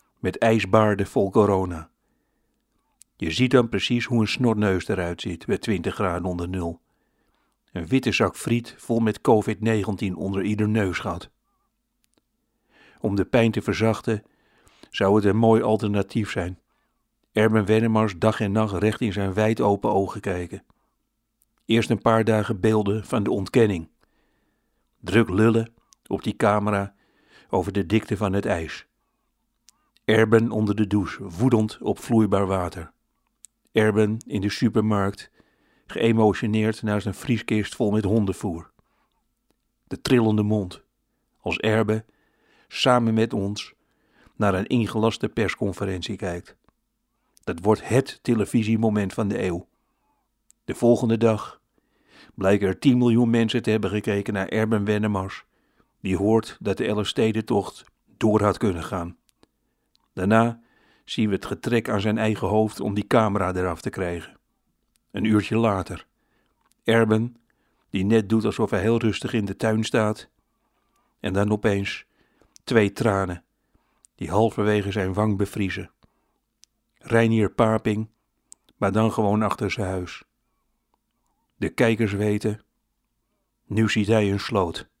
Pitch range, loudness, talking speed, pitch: 100-110 Hz, -23 LUFS, 135 wpm, 105 Hz